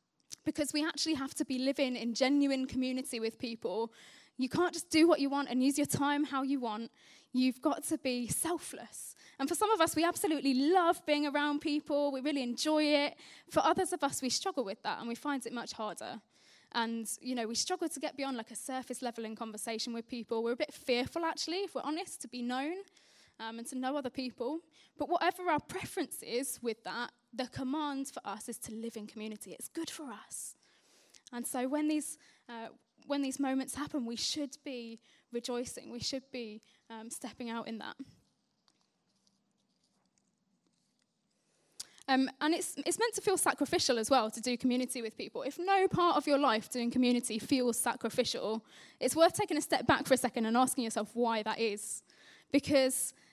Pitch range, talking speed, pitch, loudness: 235-300 Hz, 195 wpm, 265 Hz, -34 LUFS